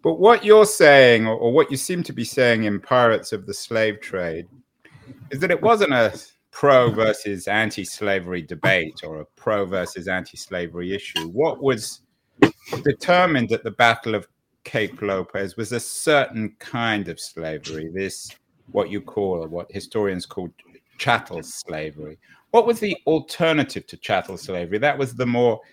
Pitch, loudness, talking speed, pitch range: 115 Hz, -20 LUFS, 160 wpm, 95-135 Hz